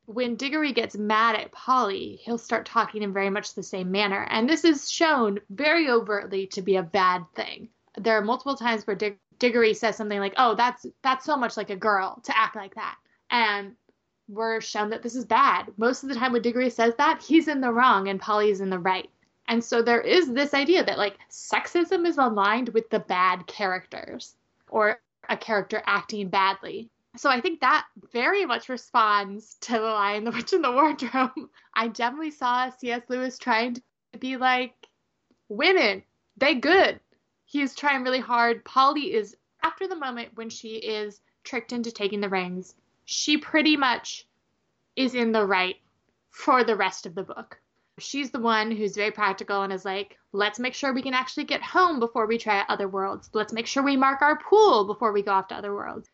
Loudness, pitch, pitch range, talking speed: -24 LUFS, 230 Hz, 205-260 Hz, 195 wpm